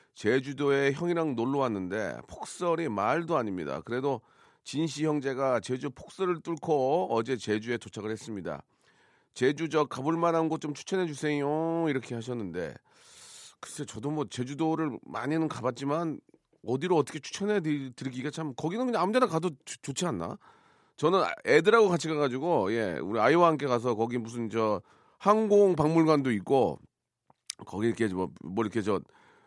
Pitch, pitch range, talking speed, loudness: 150 Hz, 125-165 Hz, 330 characters per minute, -29 LUFS